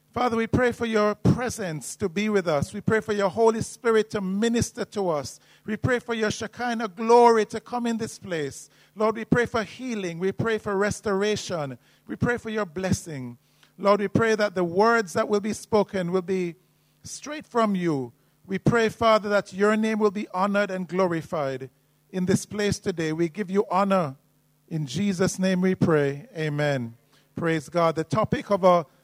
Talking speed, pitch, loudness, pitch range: 190 wpm, 200 Hz, -25 LUFS, 170-220 Hz